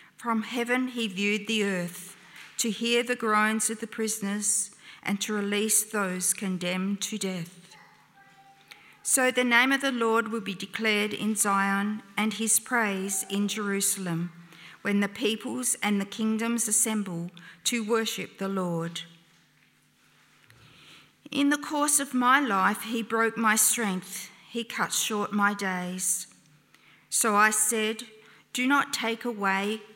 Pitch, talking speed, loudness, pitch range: 210 Hz, 140 wpm, -26 LUFS, 195-230 Hz